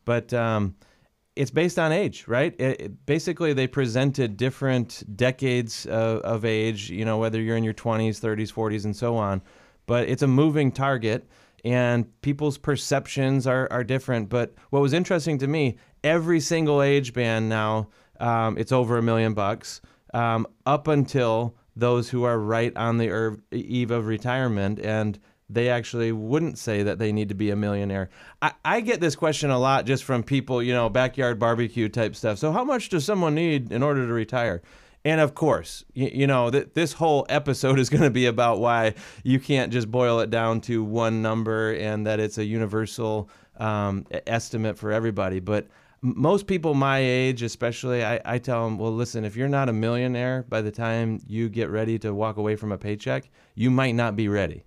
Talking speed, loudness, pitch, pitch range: 195 wpm, -24 LUFS, 120 Hz, 110-135 Hz